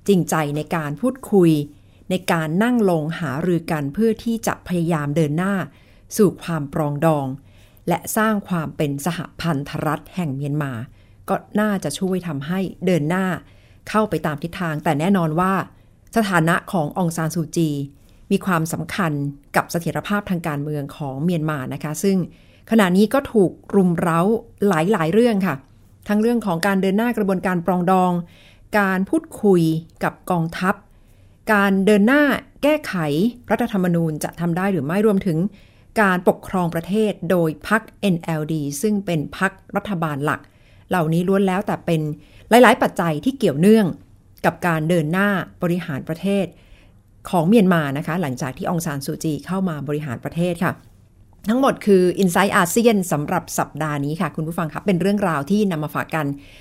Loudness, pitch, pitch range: -20 LUFS, 175 Hz, 150-200 Hz